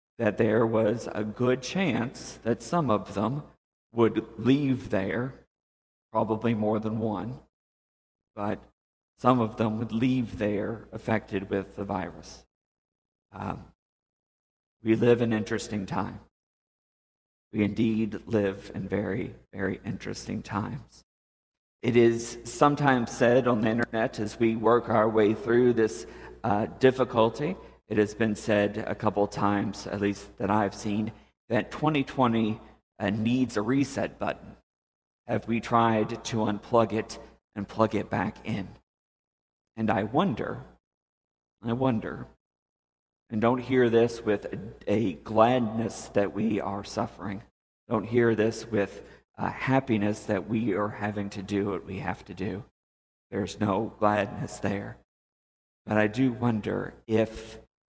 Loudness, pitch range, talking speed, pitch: -28 LUFS, 100-115 Hz, 135 wpm, 110 Hz